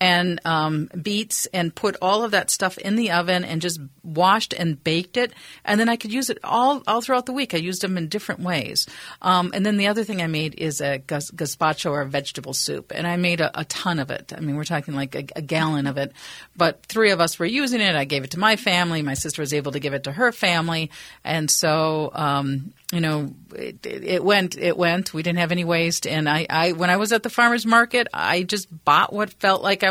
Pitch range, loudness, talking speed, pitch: 155-205 Hz, -22 LUFS, 250 wpm, 175 Hz